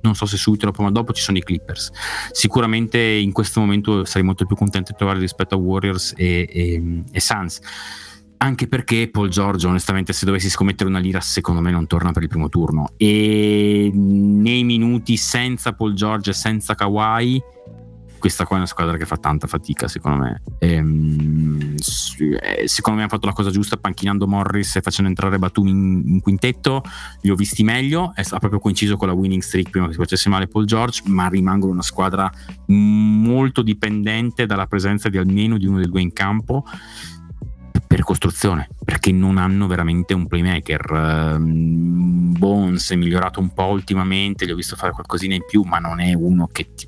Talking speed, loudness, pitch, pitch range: 185 wpm, -18 LUFS, 95 Hz, 90-105 Hz